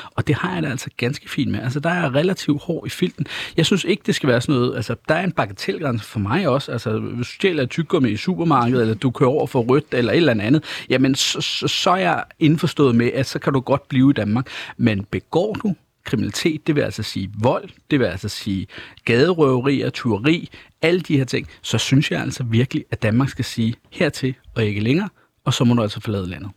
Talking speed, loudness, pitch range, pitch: 240 wpm, -20 LUFS, 115-155 Hz, 135 Hz